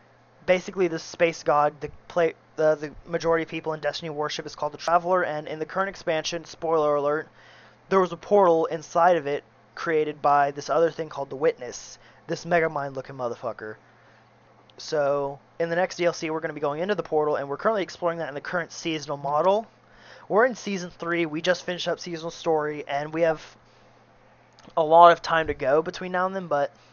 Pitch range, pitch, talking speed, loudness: 145-170 Hz, 160 Hz, 205 wpm, -25 LUFS